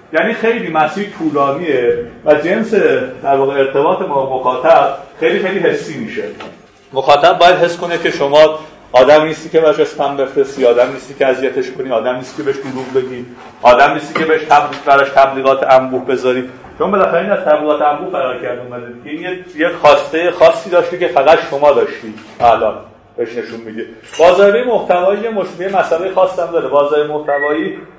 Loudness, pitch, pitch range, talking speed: -13 LUFS, 150 Hz, 135-175 Hz, 155 wpm